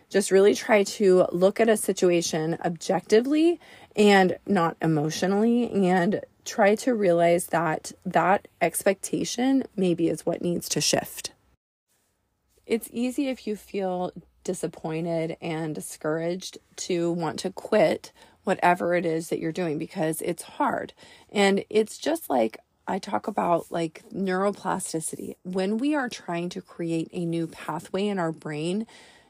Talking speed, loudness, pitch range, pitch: 135 wpm, -25 LUFS, 165-205 Hz, 185 Hz